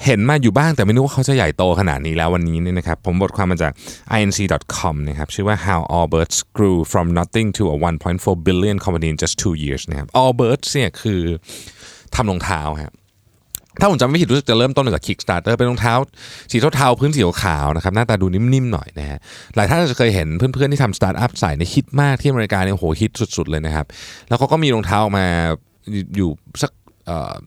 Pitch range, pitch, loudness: 85-120 Hz, 100 Hz, -18 LUFS